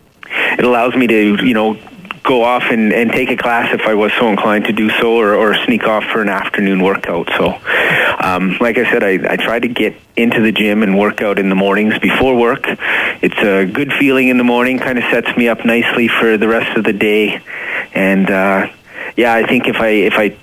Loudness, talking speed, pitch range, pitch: -12 LUFS, 230 wpm, 100-120 Hz, 110 Hz